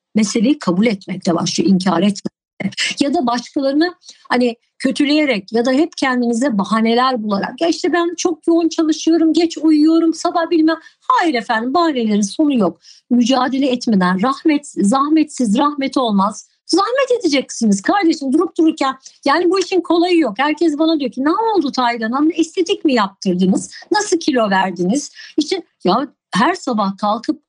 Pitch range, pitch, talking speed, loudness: 230-330 Hz, 280 Hz, 145 wpm, -16 LUFS